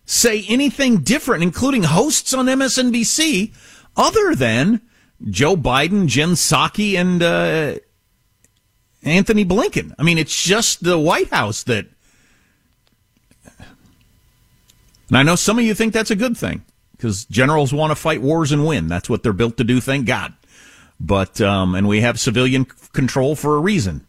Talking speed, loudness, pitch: 155 wpm, -17 LUFS, 155 Hz